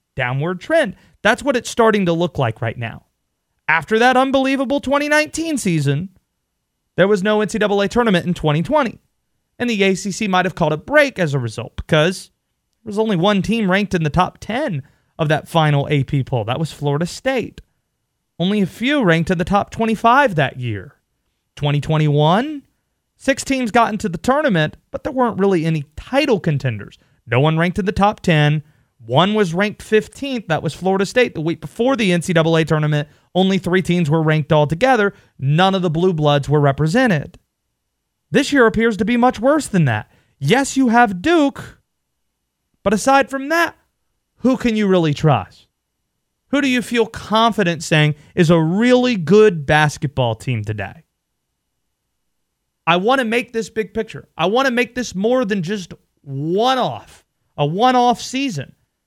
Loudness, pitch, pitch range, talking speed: -17 LUFS, 185 Hz, 150-235 Hz, 170 wpm